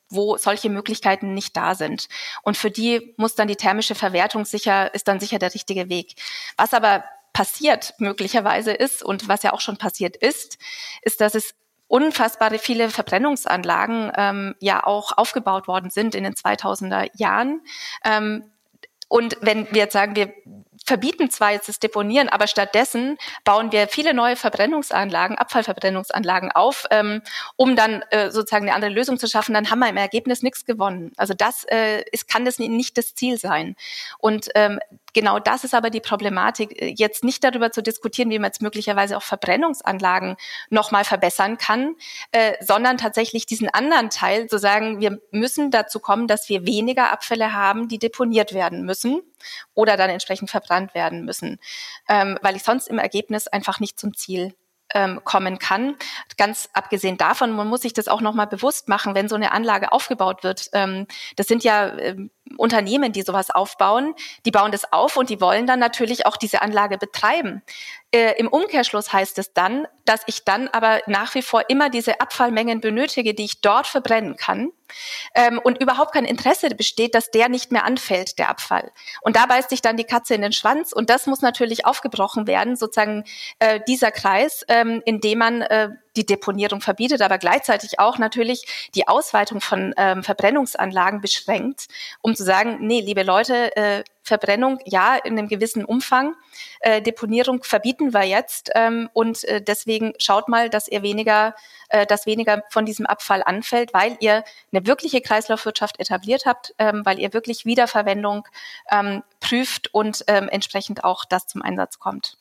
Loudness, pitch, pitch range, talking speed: -20 LUFS, 220 Hz, 205-245 Hz, 175 wpm